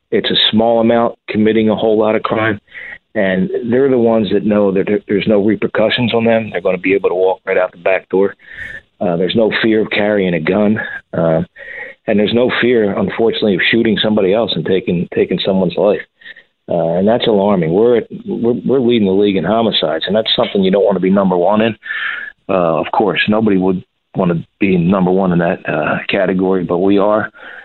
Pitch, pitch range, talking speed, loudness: 105 Hz, 95-110 Hz, 215 wpm, -14 LUFS